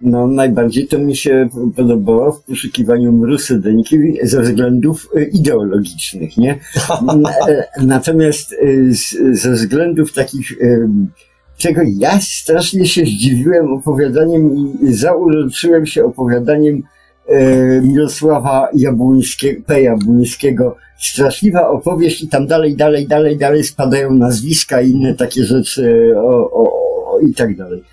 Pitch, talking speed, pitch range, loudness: 140 Hz, 110 wpm, 125-160 Hz, -12 LUFS